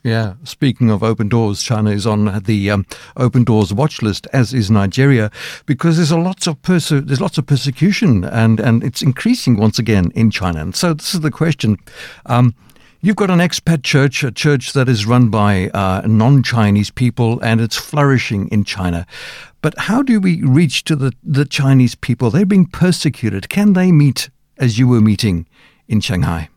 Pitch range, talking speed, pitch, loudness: 110-150 Hz, 190 wpm, 125 Hz, -15 LUFS